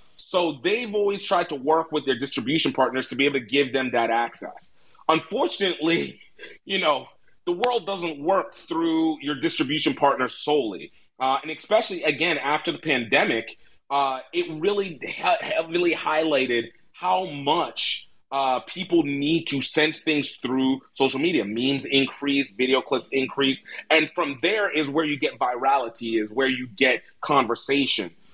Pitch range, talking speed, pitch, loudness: 135-170 Hz, 150 wpm, 150 Hz, -24 LUFS